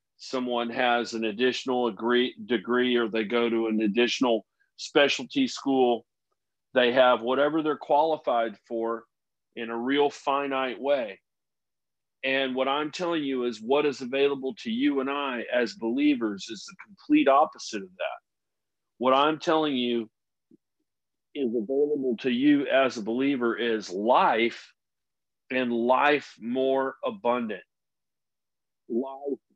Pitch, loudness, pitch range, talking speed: 130 Hz, -26 LUFS, 120-140 Hz, 130 wpm